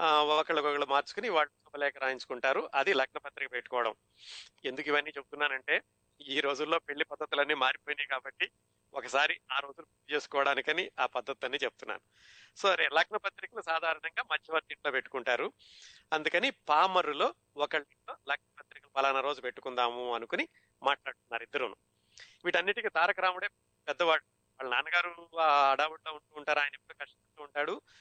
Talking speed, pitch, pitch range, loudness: 120 wpm, 145 Hz, 135-155 Hz, -32 LUFS